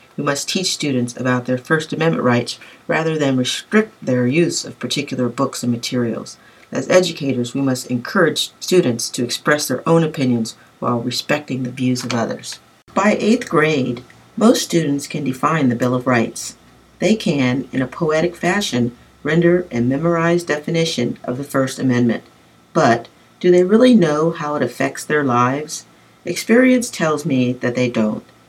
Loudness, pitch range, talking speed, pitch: -18 LUFS, 125-165 Hz, 160 wpm, 135 Hz